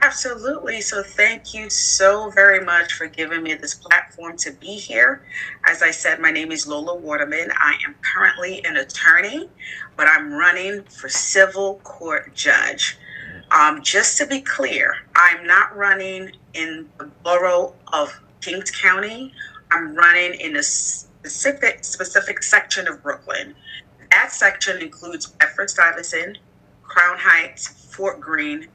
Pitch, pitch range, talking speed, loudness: 190 Hz, 165-210 Hz, 140 wpm, -17 LUFS